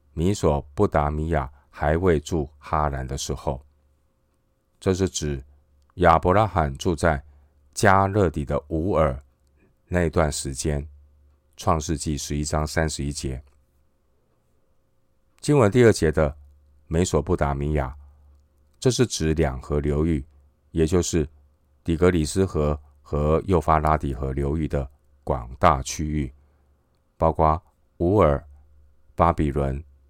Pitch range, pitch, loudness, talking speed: 70-80 Hz, 75 Hz, -23 LUFS, 180 characters per minute